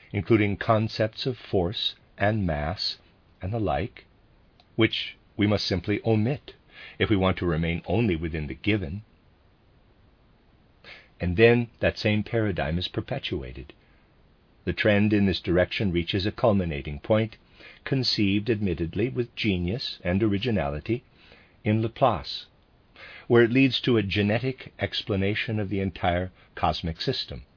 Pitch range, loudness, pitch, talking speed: 90-115 Hz, -26 LUFS, 105 Hz, 130 wpm